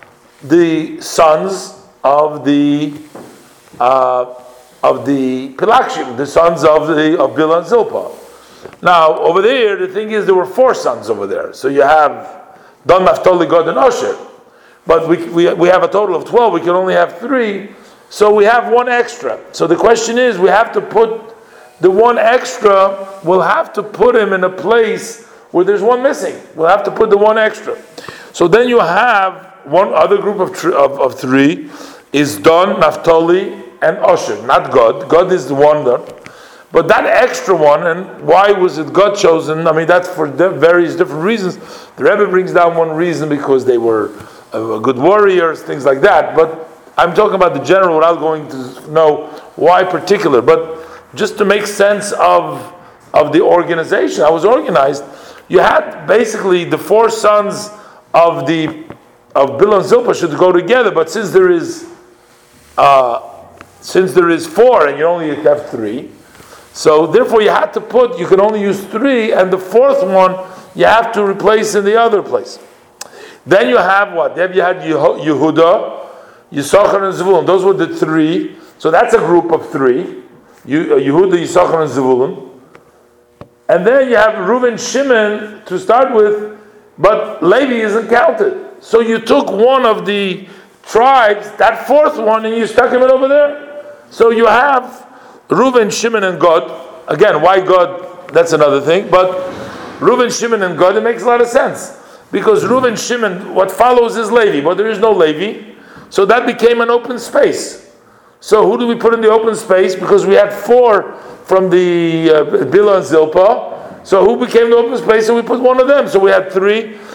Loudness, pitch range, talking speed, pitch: -11 LUFS, 170-250 Hz, 180 wpm, 210 Hz